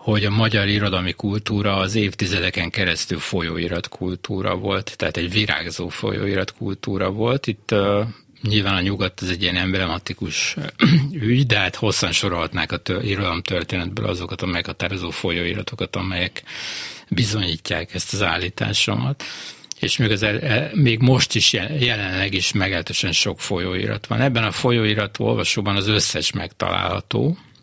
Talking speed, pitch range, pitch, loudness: 135 wpm, 90-110 Hz, 100 Hz, -20 LUFS